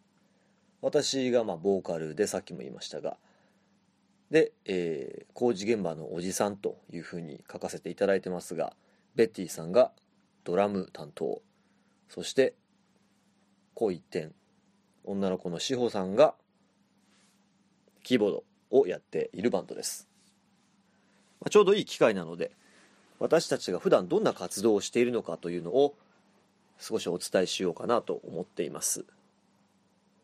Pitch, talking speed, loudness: 120 Hz, 285 characters per minute, -30 LUFS